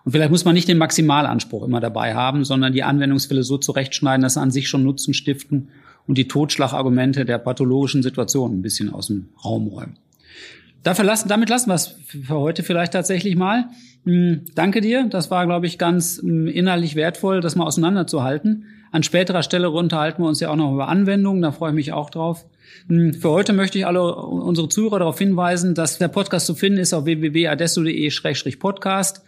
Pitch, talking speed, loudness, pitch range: 165 Hz, 185 wpm, -19 LUFS, 140-180 Hz